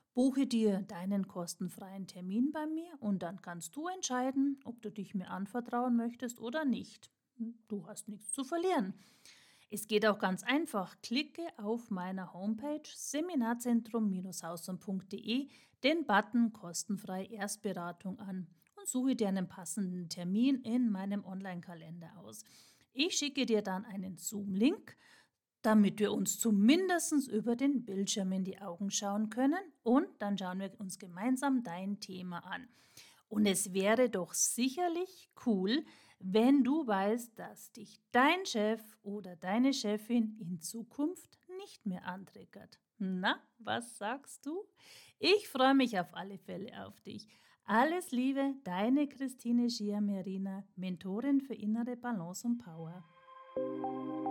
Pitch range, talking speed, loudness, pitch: 195-260 Hz, 135 wpm, -35 LUFS, 215 Hz